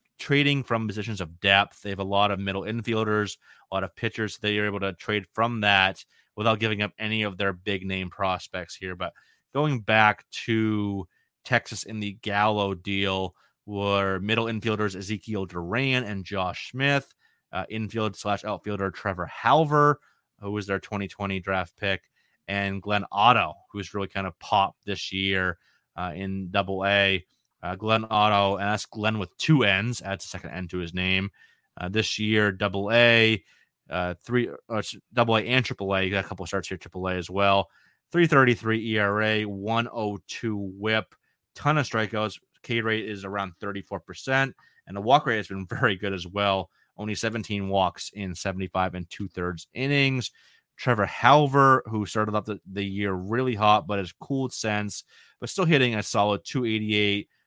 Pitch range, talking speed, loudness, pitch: 95-110 Hz, 170 wpm, -25 LUFS, 105 Hz